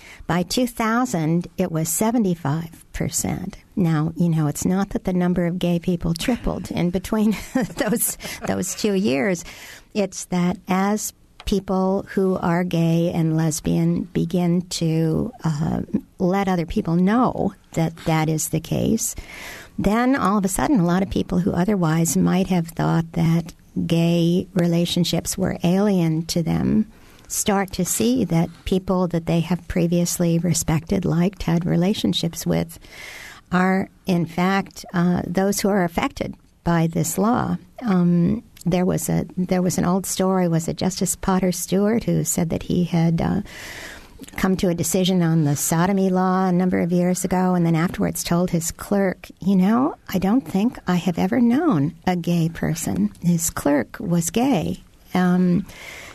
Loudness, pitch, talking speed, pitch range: -21 LUFS, 180 Hz, 155 wpm, 170-195 Hz